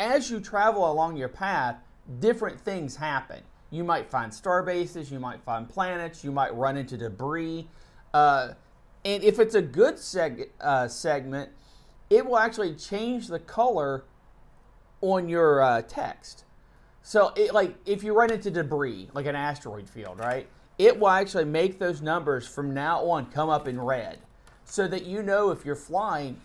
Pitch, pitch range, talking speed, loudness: 165 Hz, 135-200 Hz, 170 wpm, -26 LUFS